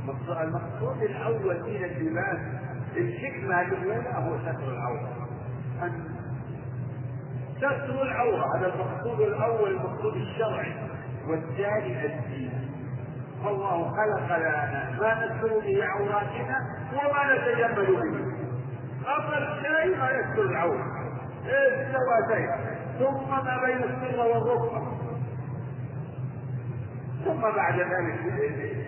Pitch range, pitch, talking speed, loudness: 125-165 Hz, 135 Hz, 85 wpm, -29 LUFS